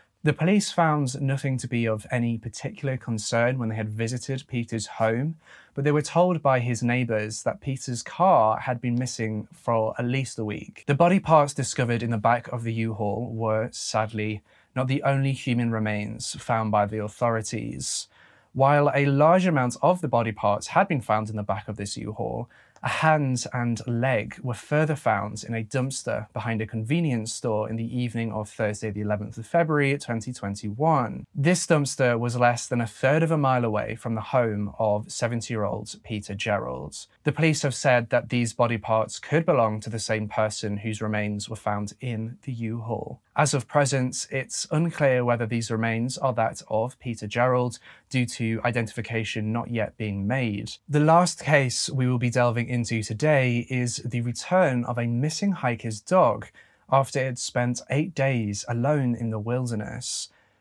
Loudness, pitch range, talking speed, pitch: -25 LUFS, 110-135 Hz, 185 wpm, 120 Hz